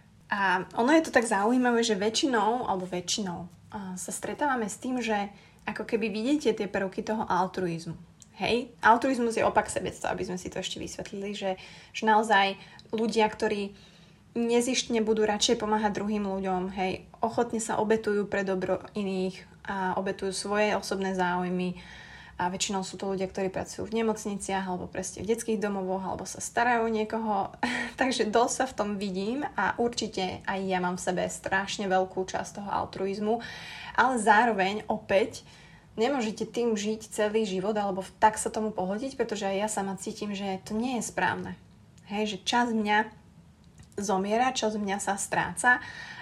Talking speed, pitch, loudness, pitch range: 165 wpm, 210 Hz, -28 LUFS, 190-225 Hz